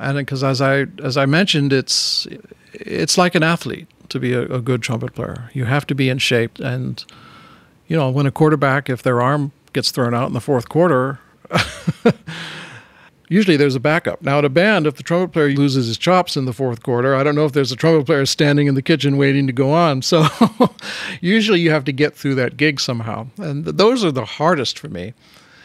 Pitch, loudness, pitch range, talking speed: 140 Hz, -17 LUFS, 130-160 Hz, 220 wpm